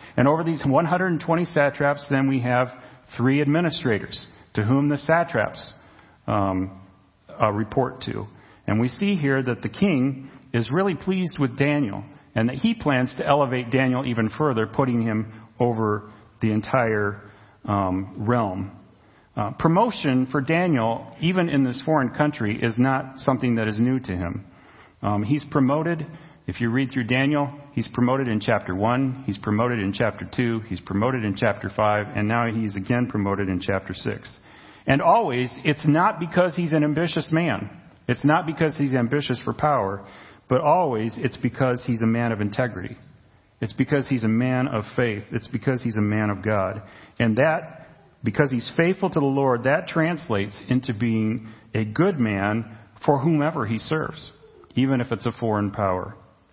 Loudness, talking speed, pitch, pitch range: -23 LUFS, 170 wpm, 125 Hz, 110-145 Hz